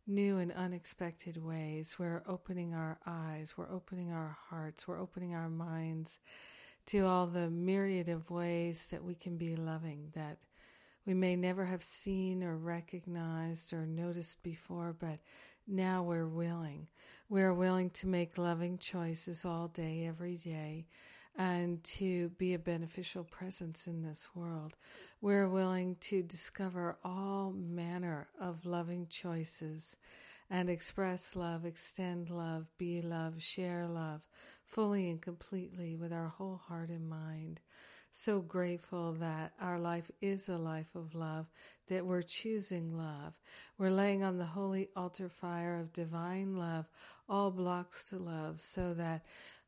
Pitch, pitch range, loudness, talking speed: 175 Hz, 165-185 Hz, -39 LUFS, 145 wpm